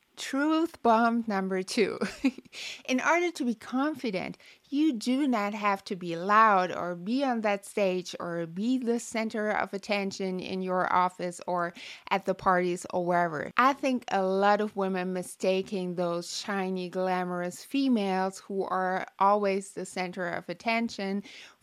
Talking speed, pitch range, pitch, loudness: 150 wpm, 185-235 Hz, 195 Hz, -29 LUFS